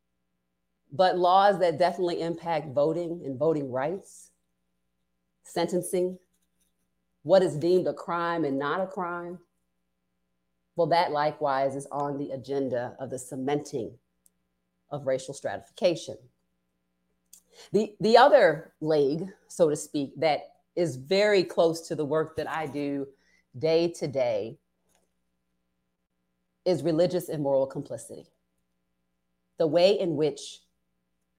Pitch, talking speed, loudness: 140 Hz, 115 wpm, -27 LUFS